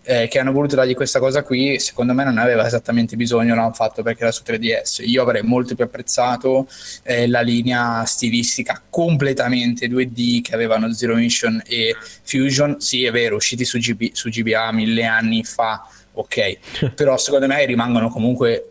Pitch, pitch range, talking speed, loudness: 120 Hz, 115-130 Hz, 175 wpm, -18 LUFS